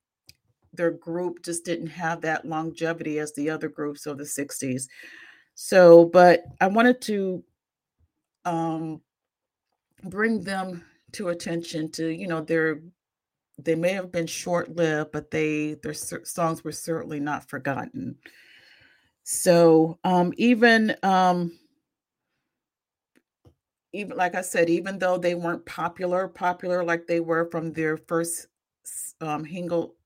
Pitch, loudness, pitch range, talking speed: 170 Hz, -24 LUFS, 160-180 Hz, 130 wpm